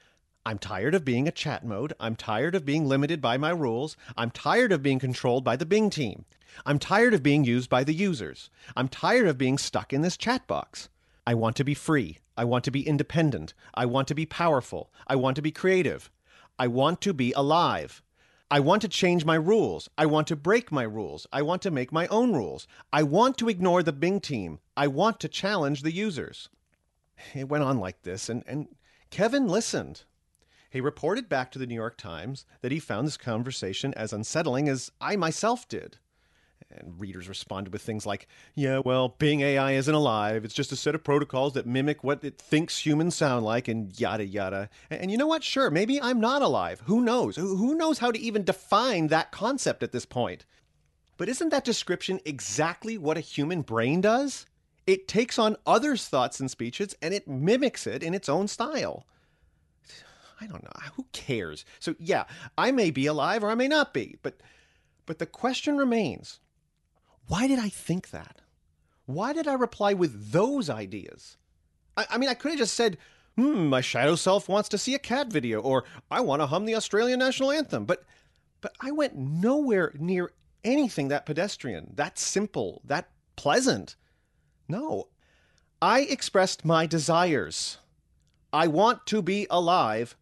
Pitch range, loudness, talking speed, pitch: 125-205 Hz, -27 LUFS, 190 wpm, 155 Hz